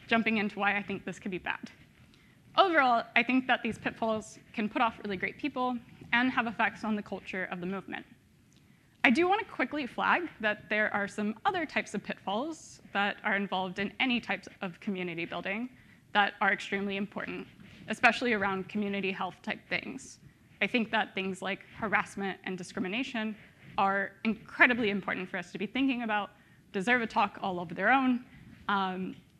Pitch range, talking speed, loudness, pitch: 195-235 Hz, 180 wpm, -31 LUFS, 210 Hz